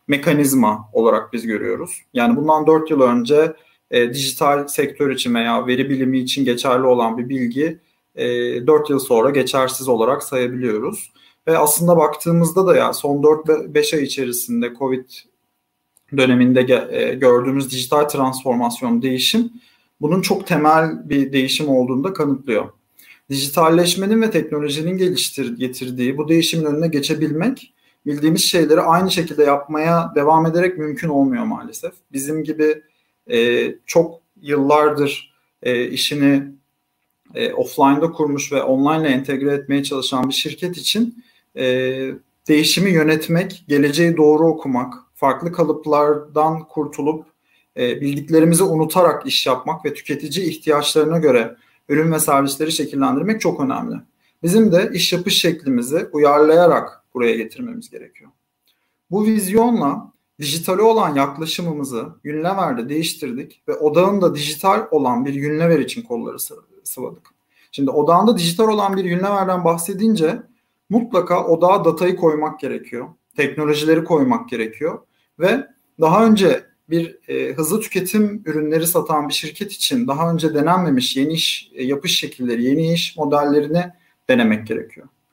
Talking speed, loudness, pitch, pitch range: 125 wpm, -17 LUFS, 155 Hz, 140-175 Hz